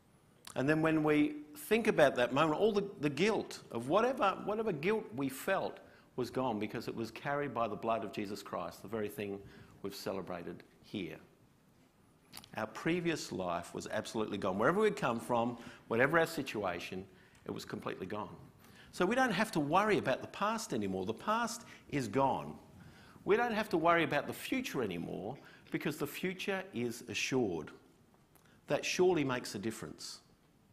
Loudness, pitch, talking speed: -35 LUFS, 150 Hz, 170 wpm